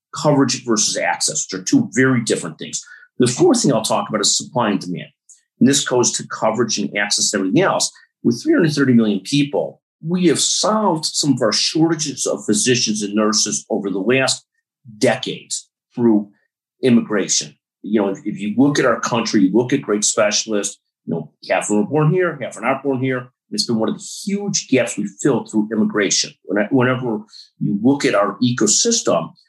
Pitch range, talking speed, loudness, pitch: 105-155 Hz, 190 wpm, -18 LUFS, 125 Hz